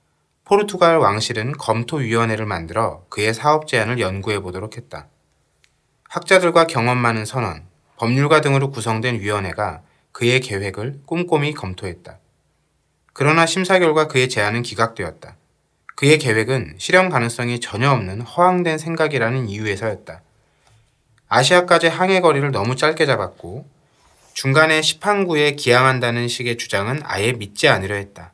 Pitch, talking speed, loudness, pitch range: 125 Hz, 330 characters per minute, -18 LUFS, 110-155 Hz